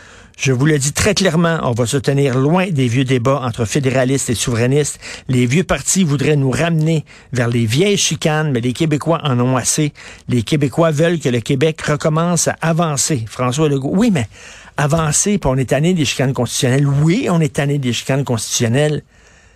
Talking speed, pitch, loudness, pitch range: 190 wpm, 145 Hz, -16 LUFS, 125-160 Hz